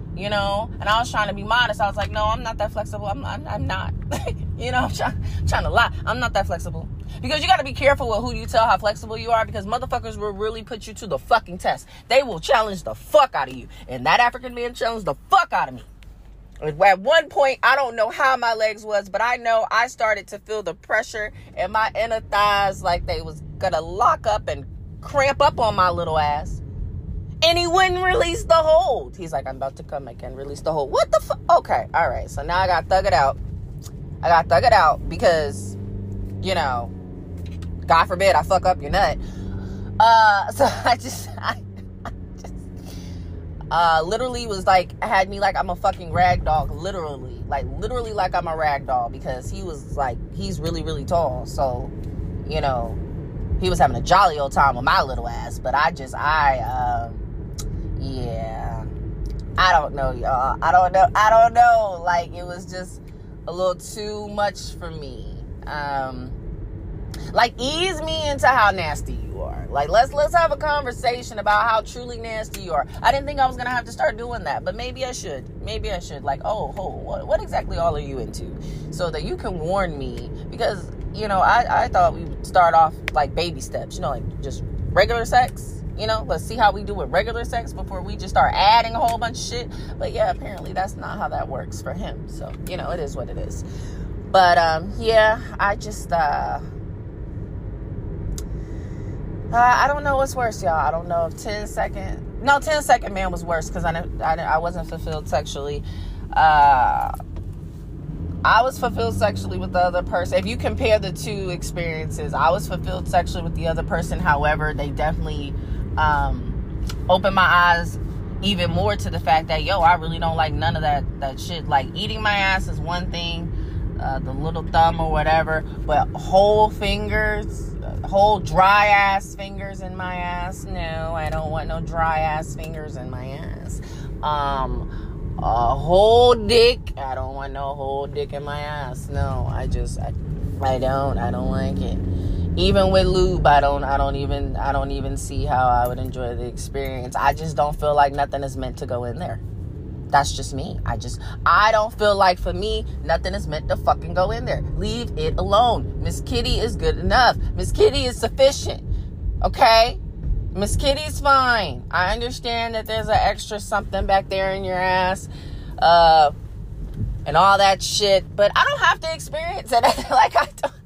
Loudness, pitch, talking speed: -21 LUFS, 155 Hz, 200 wpm